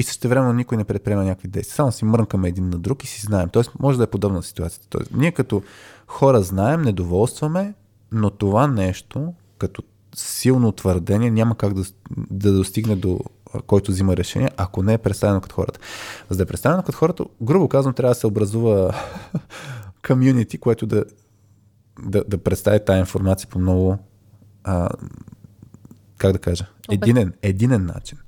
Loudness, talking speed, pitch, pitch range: -20 LUFS, 170 wpm, 105 Hz, 95-120 Hz